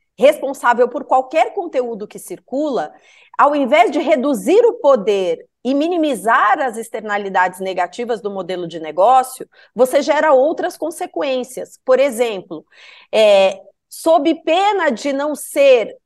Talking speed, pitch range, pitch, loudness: 125 wpm, 215-315 Hz, 270 Hz, -16 LUFS